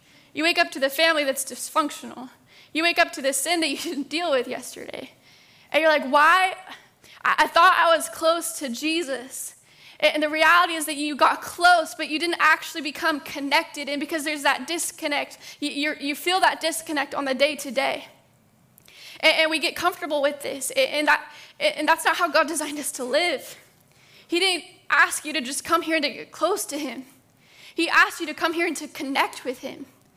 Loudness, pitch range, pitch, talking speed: -22 LUFS, 285-330 Hz, 310 Hz, 195 wpm